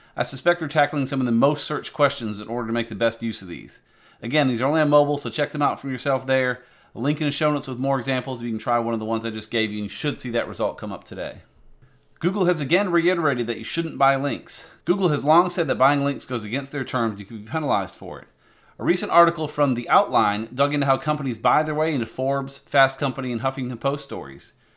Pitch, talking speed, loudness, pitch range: 135 Hz, 260 wpm, -23 LUFS, 120-150 Hz